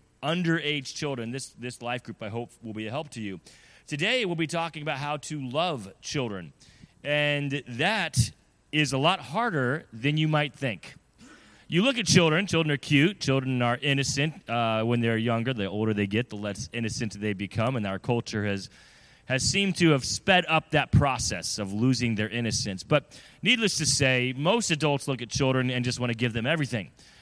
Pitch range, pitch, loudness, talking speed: 115-150 Hz, 130 Hz, -26 LUFS, 195 wpm